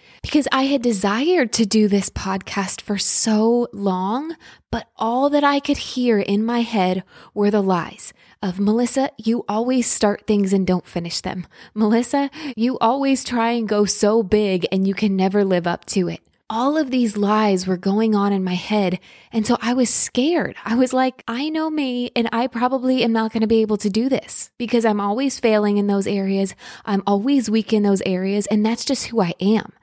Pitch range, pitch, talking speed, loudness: 200-245 Hz, 220 Hz, 205 wpm, -19 LUFS